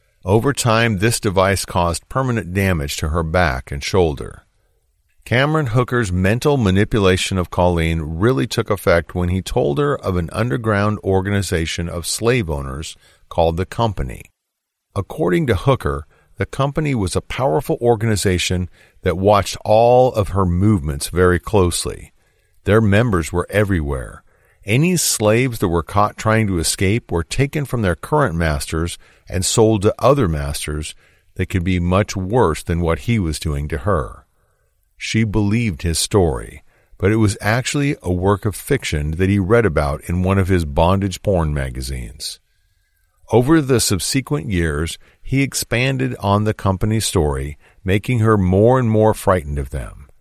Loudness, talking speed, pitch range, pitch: -18 LUFS, 155 wpm, 85-110 Hz, 95 Hz